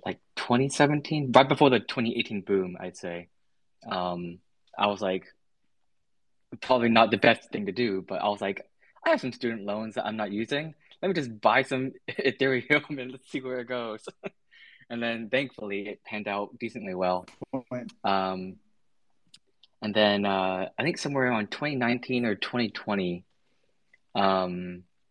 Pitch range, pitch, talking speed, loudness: 100-130 Hz, 115 Hz, 165 wpm, -27 LUFS